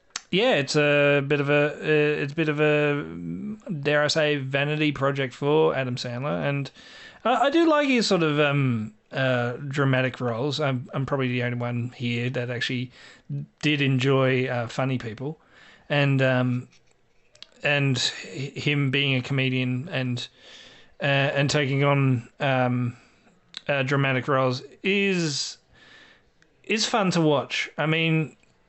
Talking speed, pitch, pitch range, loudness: 140 wpm, 140 Hz, 125-150 Hz, -24 LUFS